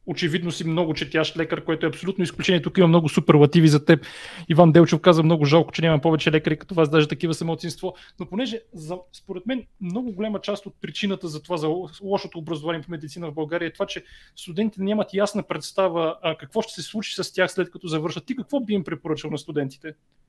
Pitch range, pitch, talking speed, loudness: 160-190 Hz, 170 Hz, 210 wpm, -22 LUFS